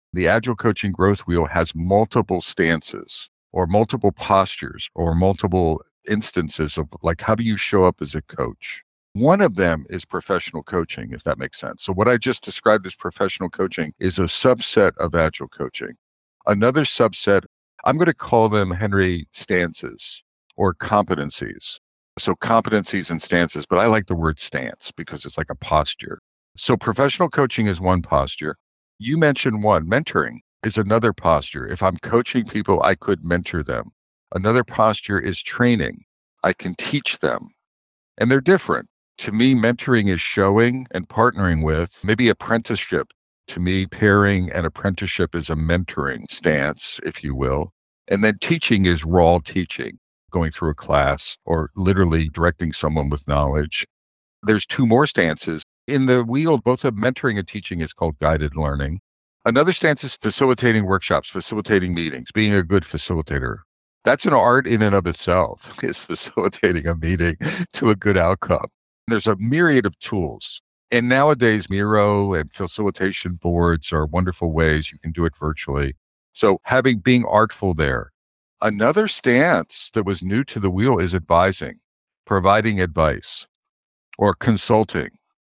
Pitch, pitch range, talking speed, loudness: 95 Hz, 85-115 Hz, 155 wpm, -20 LUFS